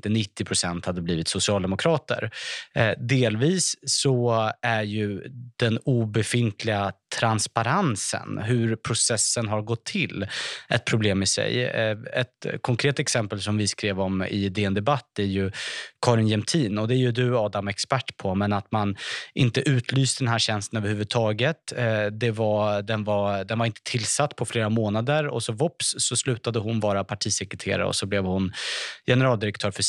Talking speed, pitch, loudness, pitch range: 165 wpm, 110 Hz, -25 LUFS, 105-125 Hz